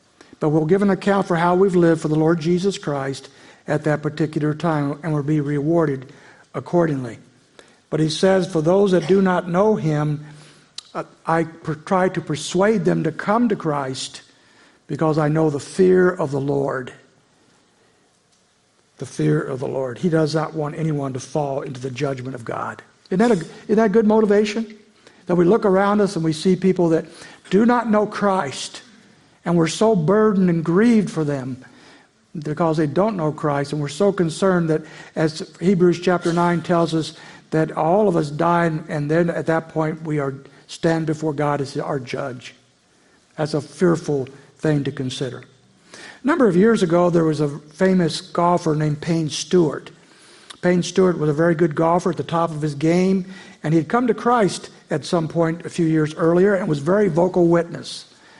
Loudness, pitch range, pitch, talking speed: -20 LUFS, 150-185 Hz, 165 Hz, 190 wpm